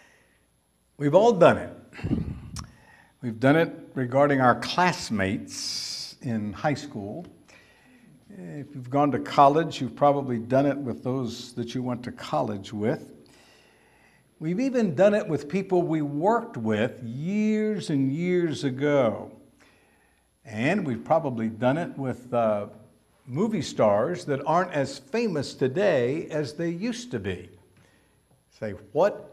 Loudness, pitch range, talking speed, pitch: -25 LUFS, 120-170 Hz, 130 wpm, 140 Hz